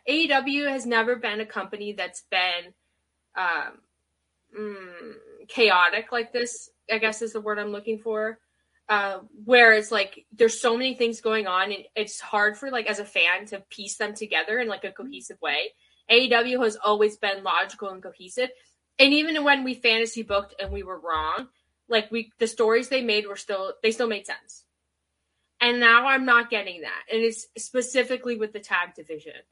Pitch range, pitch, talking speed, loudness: 200-240 Hz, 220 Hz, 185 wpm, -23 LUFS